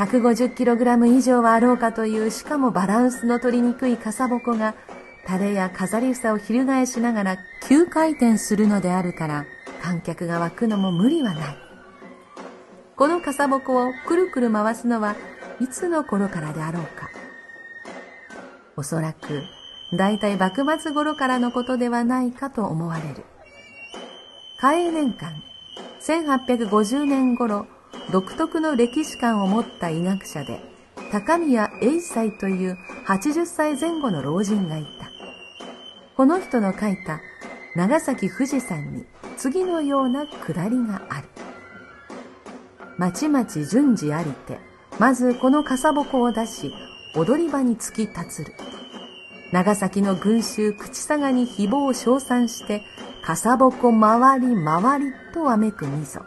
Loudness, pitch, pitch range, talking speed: -22 LUFS, 235 Hz, 195-265 Hz, 240 characters per minute